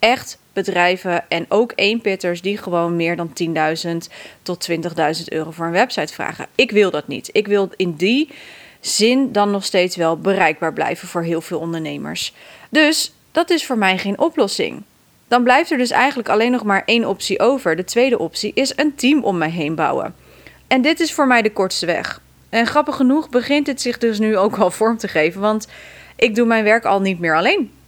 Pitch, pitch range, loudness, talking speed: 200 Hz, 175-245 Hz, -17 LUFS, 200 wpm